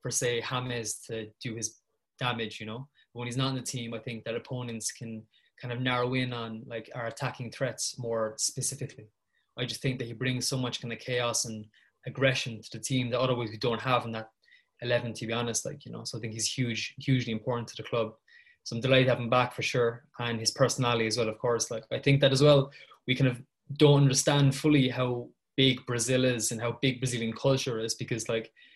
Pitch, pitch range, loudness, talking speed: 125 Hz, 115-130 Hz, -29 LUFS, 230 wpm